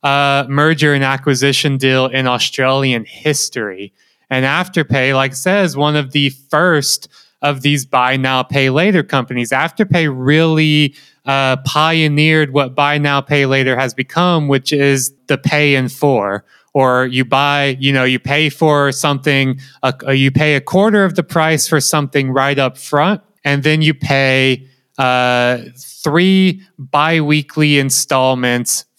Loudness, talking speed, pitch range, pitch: -13 LUFS, 145 wpm, 130-150 Hz, 140 Hz